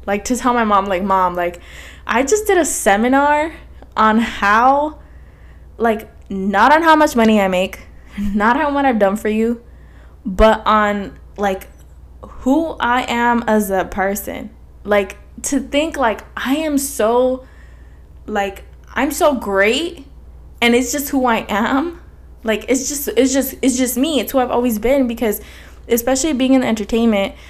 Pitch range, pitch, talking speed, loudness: 205-270 Hz, 235 Hz, 165 wpm, -16 LUFS